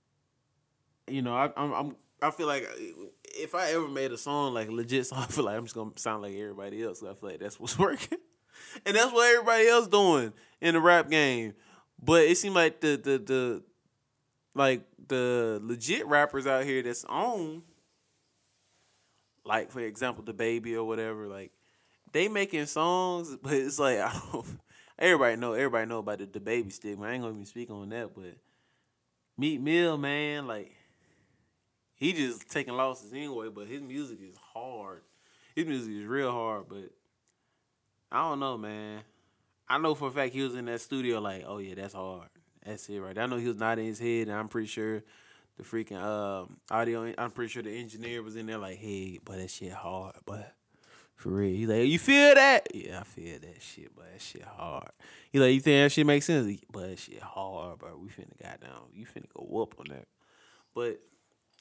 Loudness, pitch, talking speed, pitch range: -29 LUFS, 120 Hz, 200 wpm, 110-145 Hz